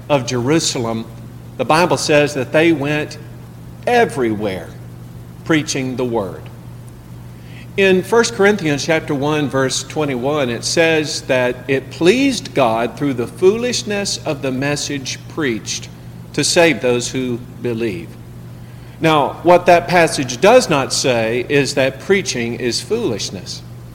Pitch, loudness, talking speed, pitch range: 135 Hz, -16 LUFS, 125 wpm, 120-155 Hz